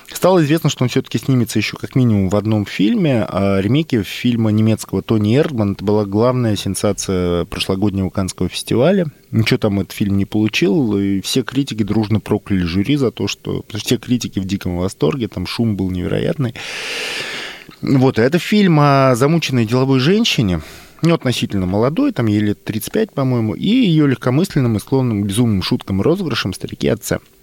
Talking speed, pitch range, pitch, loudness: 170 wpm, 100-140 Hz, 115 Hz, -17 LUFS